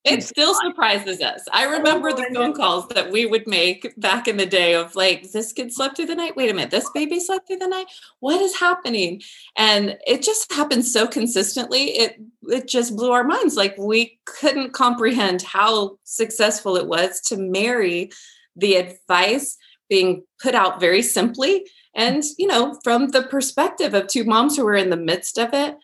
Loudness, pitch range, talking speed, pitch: -19 LUFS, 195-295 Hz, 190 wpm, 235 Hz